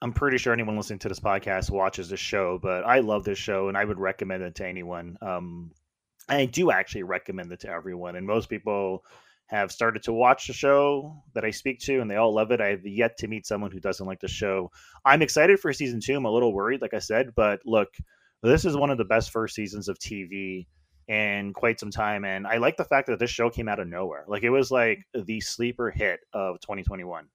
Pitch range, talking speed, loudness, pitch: 95-120 Hz, 240 wpm, -26 LUFS, 105 Hz